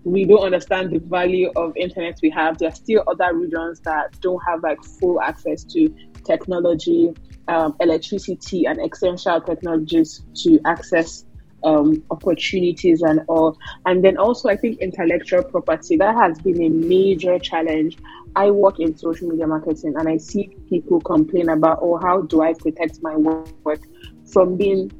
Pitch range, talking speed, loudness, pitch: 160-185 Hz, 160 wpm, -19 LUFS, 170 Hz